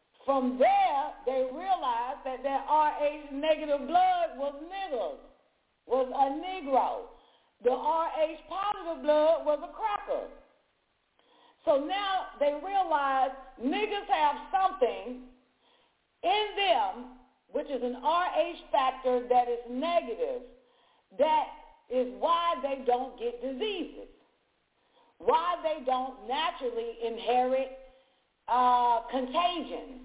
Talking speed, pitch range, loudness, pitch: 105 wpm, 255-350 Hz, -29 LUFS, 290 Hz